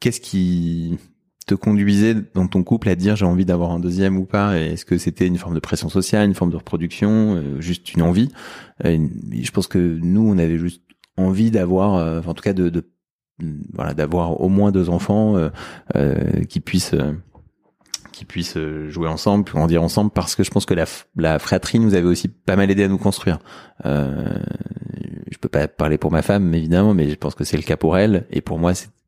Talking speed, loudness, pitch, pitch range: 215 wpm, -19 LUFS, 90 Hz, 85-100 Hz